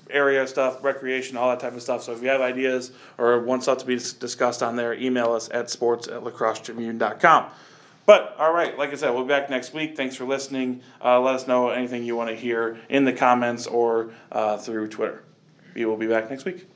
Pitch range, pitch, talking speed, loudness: 120-130 Hz, 125 Hz, 220 wpm, -23 LUFS